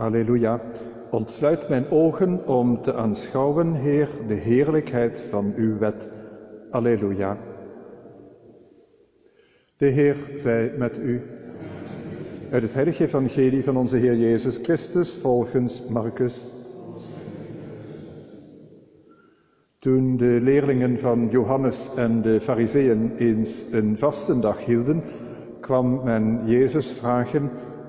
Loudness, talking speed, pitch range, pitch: -22 LUFS, 100 wpm, 115-140 Hz, 125 Hz